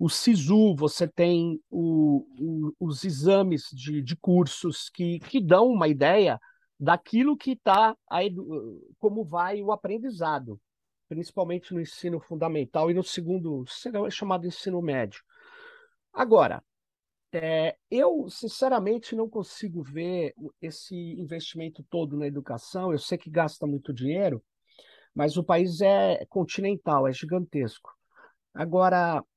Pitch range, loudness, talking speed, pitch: 155-200 Hz, -26 LUFS, 125 wpm, 170 Hz